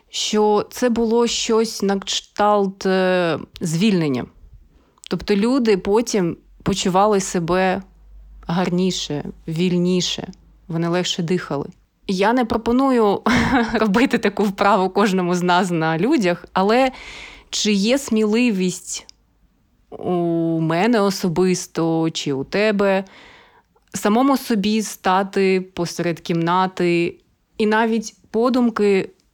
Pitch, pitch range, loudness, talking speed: 195 Hz, 180-220 Hz, -19 LUFS, 95 wpm